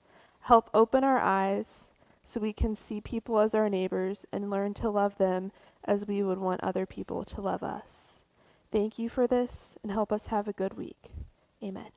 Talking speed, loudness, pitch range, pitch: 190 wpm, -30 LUFS, 195-225 Hz, 210 Hz